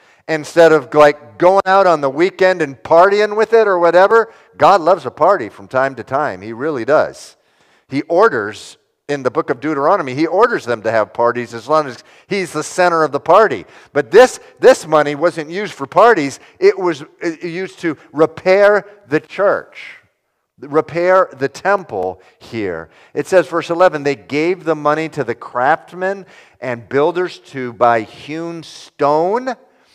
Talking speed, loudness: 170 wpm, -15 LUFS